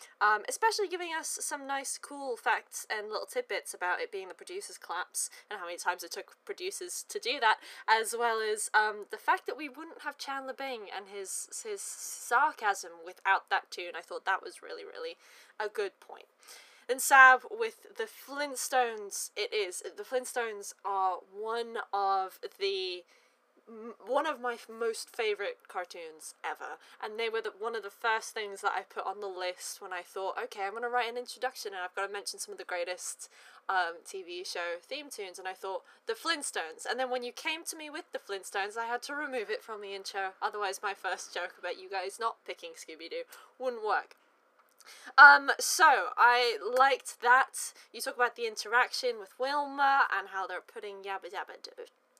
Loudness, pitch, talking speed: -31 LUFS, 260 Hz, 195 wpm